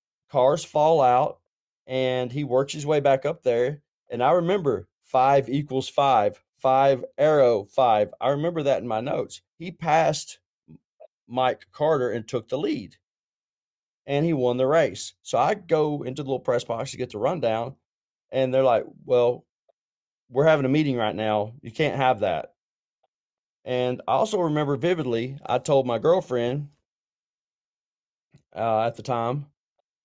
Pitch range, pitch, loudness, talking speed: 125-150 Hz, 130 Hz, -24 LUFS, 155 wpm